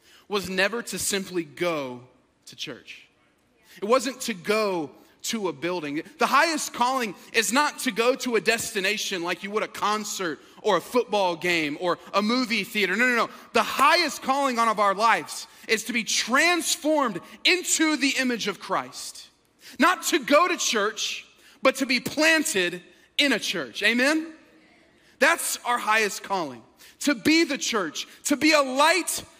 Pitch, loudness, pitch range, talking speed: 235 Hz, -23 LUFS, 200-285 Hz, 165 wpm